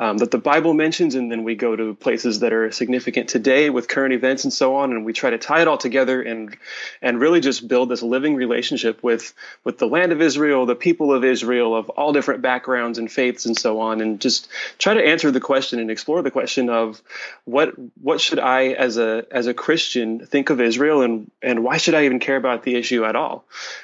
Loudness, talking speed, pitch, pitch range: -19 LUFS, 230 wpm, 125 Hz, 115-140 Hz